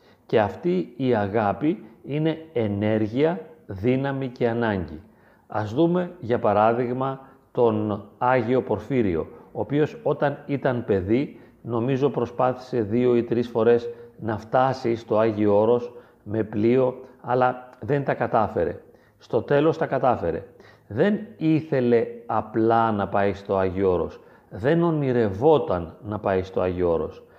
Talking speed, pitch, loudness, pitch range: 125 wpm, 120 Hz, -23 LUFS, 110-135 Hz